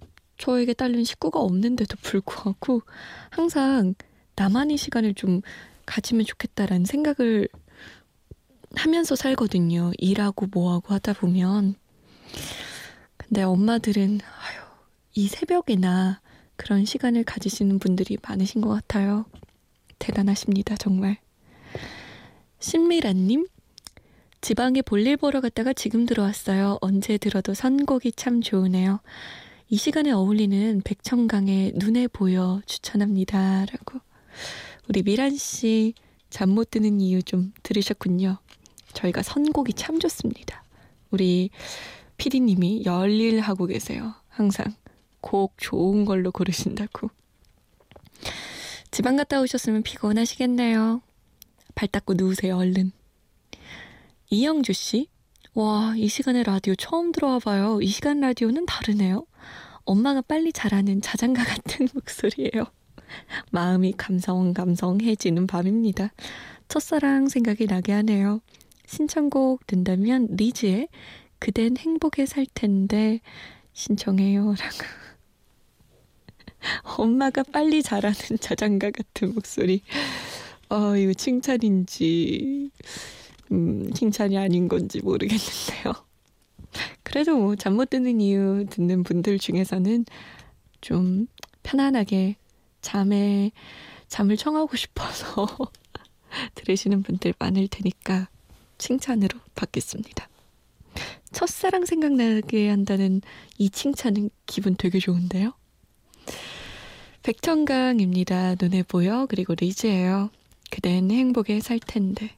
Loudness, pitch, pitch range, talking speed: -24 LUFS, 210 Hz, 195-245 Hz, 245 characters per minute